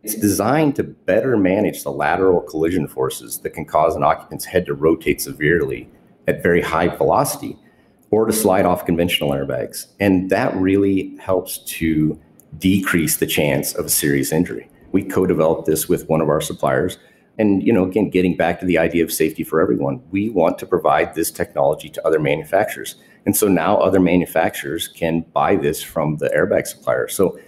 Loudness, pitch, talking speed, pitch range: -18 LUFS, 90 Hz, 180 wpm, 80-100 Hz